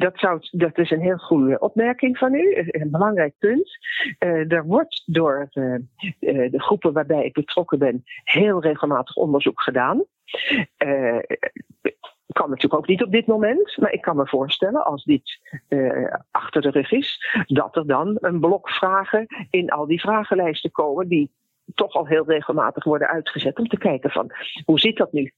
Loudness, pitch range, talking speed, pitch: -21 LUFS, 150-210 Hz, 175 wpm, 175 Hz